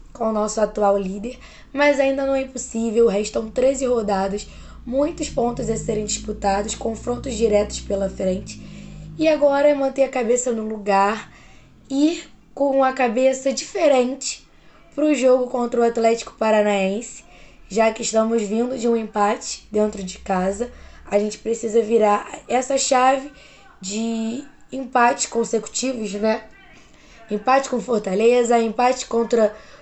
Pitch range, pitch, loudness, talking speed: 210-260 Hz, 230 Hz, -20 LUFS, 135 wpm